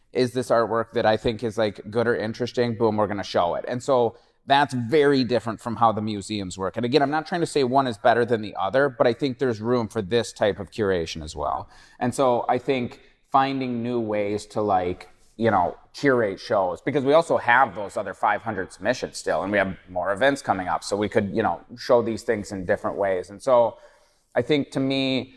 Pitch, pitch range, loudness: 120 Hz, 105-135 Hz, -23 LUFS